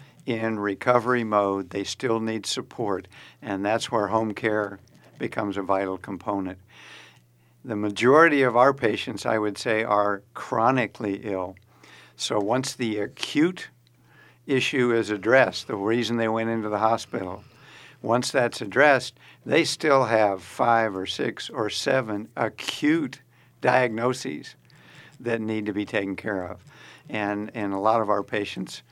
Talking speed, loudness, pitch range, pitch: 140 wpm, -24 LUFS, 105-120 Hz, 110 Hz